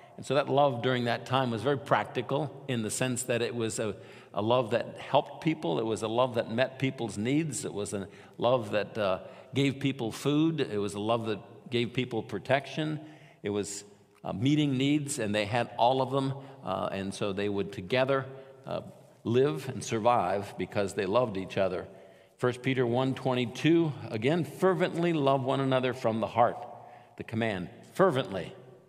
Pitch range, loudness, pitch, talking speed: 105-135 Hz, -30 LUFS, 125 Hz, 185 wpm